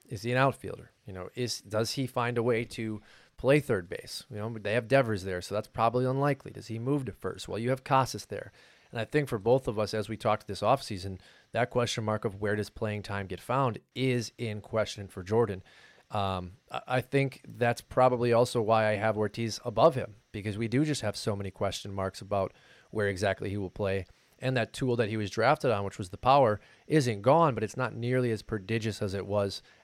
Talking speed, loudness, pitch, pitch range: 225 wpm, -30 LUFS, 110 Hz, 105-125 Hz